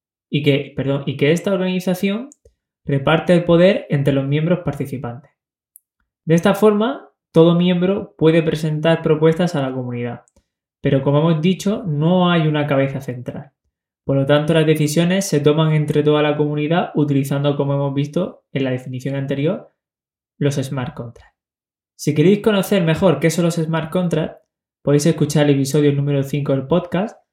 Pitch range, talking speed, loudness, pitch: 140-170 Hz, 160 wpm, -18 LUFS, 150 Hz